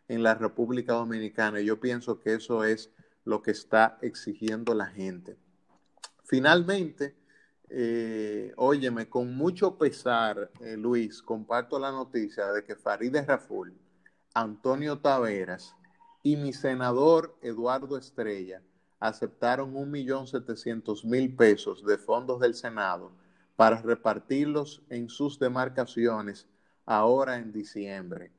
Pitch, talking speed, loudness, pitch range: 115 Hz, 115 wpm, -29 LUFS, 110-135 Hz